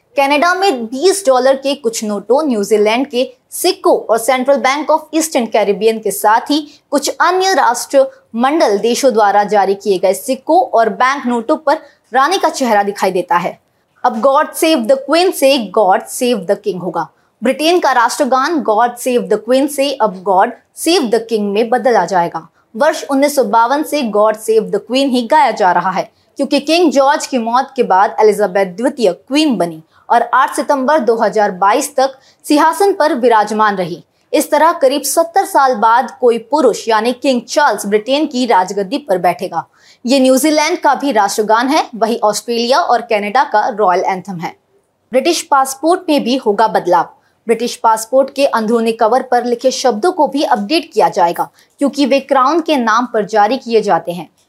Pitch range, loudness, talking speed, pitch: 215-285 Hz, -13 LUFS, 170 wpm, 255 Hz